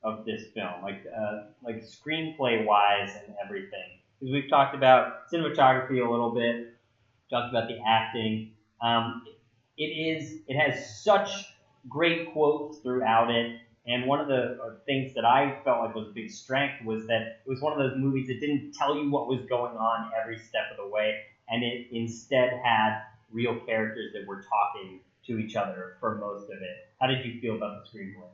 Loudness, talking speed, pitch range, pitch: -28 LUFS, 190 wpm, 110-135 Hz, 115 Hz